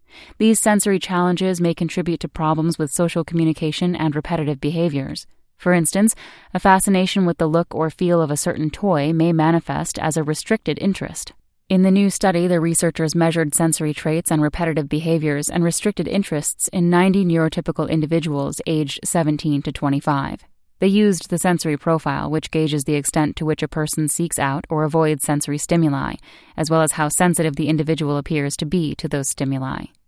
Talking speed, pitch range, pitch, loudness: 175 wpm, 155-175 Hz, 160 Hz, -19 LUFS